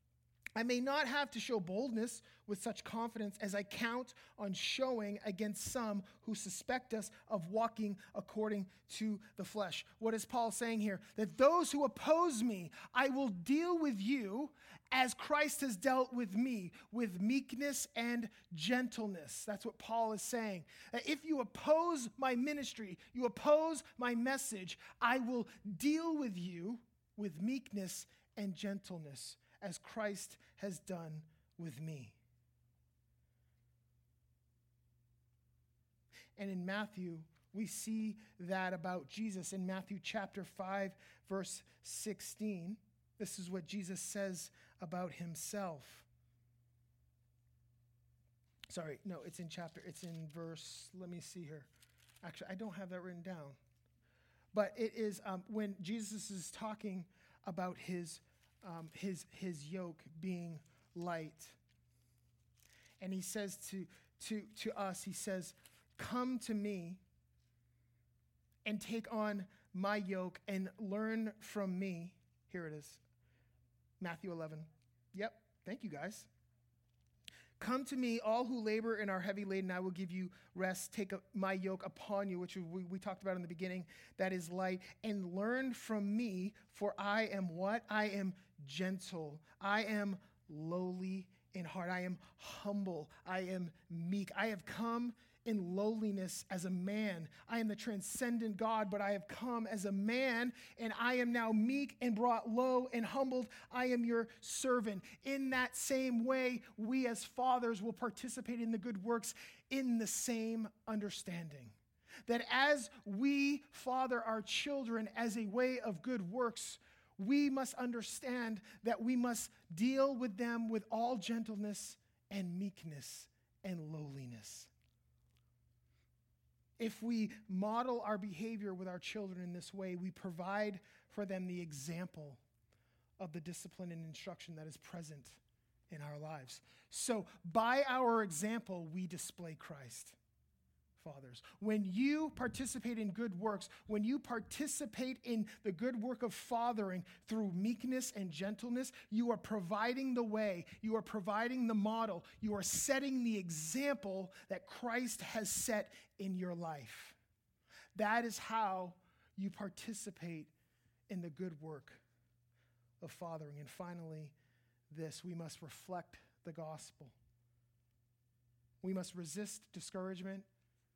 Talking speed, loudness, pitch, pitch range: 140 wpm, -41 LUFS, 200 Hz, 170-230 Hz